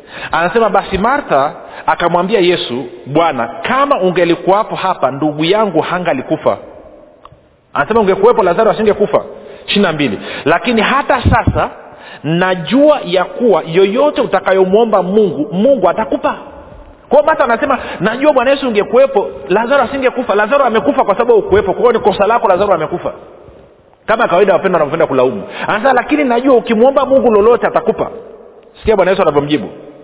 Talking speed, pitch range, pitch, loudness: 130 wpm, 180-270 Hz, 215 Hz, -12 LUFS